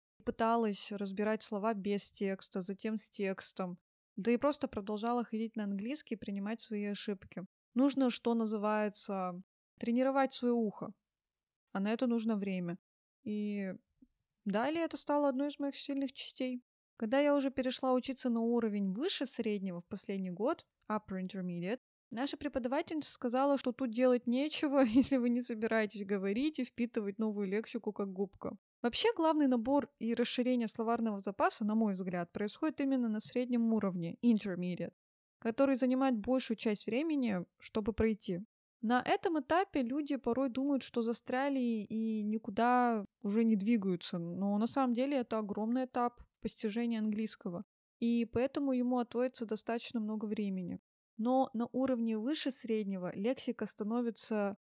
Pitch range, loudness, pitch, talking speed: 210-260 Hz, -35 LUFS, 230 Hz, 145 wpm